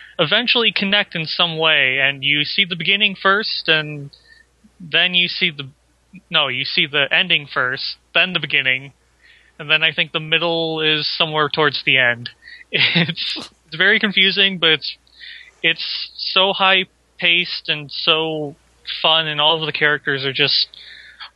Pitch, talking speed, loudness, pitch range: 165 Hz, 155 wpm, -16 LUFS, 150-190 Hz